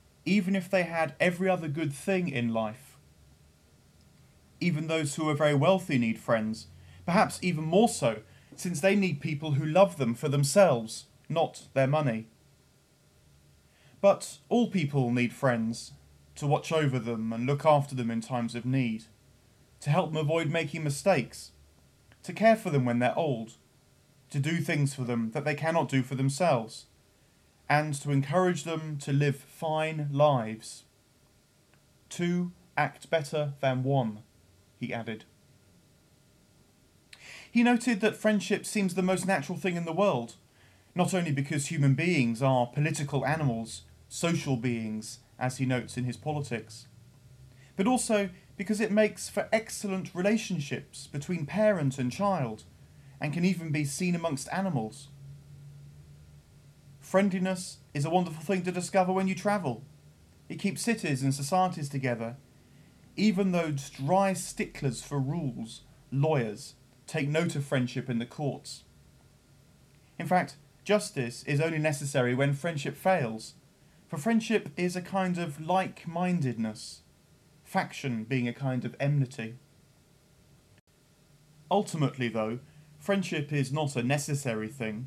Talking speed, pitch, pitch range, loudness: 140 wpm, 145 Hz, 125-175 Hz, -29 LUFS